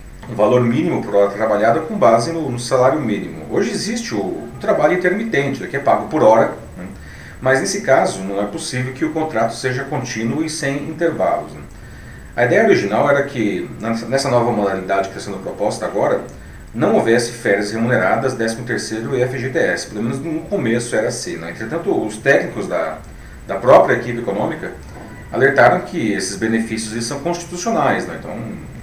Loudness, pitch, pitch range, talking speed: -18 LUFS, 120 Hz, 110-145 Hz, 175 wpm